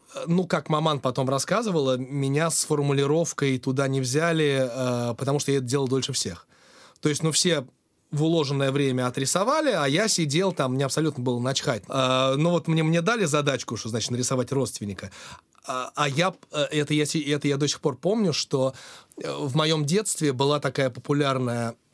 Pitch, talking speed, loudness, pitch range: 145 Hz, 175 wpm, -24 LUFS, 130-160 Hz